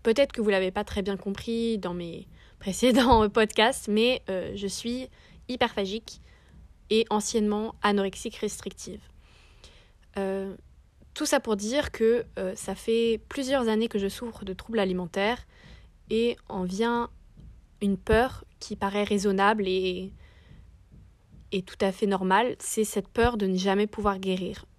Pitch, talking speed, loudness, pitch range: 210 Hz, 150 wpm, -27 LUFS, 195-230 Hz